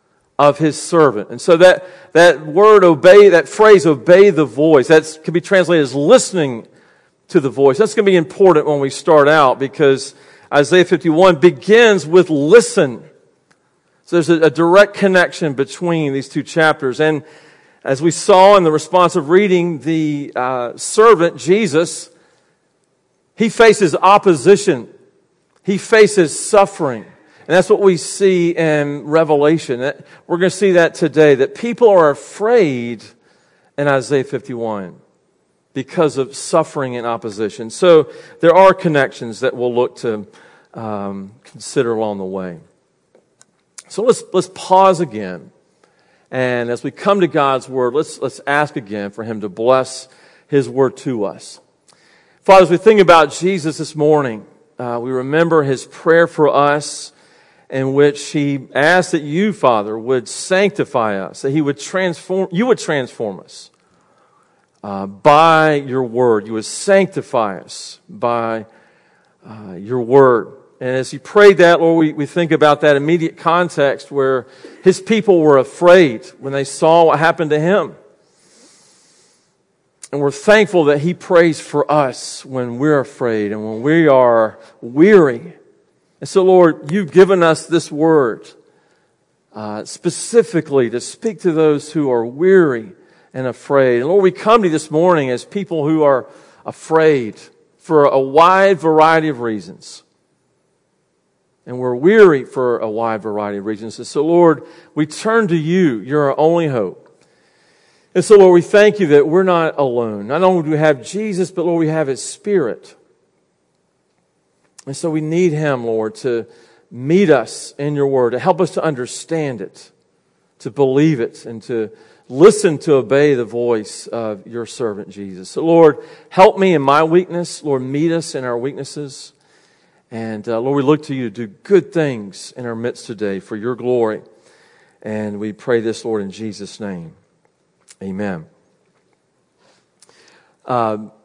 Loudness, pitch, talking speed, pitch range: -14 LUFS, 150 Hz, 155 wpm, 125-180 Hz